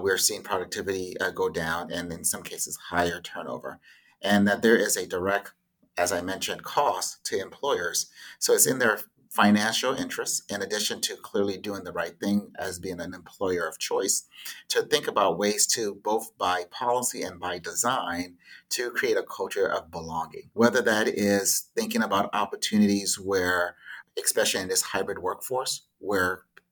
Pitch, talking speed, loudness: 115 Hz, 165 wpm, -26 LUFS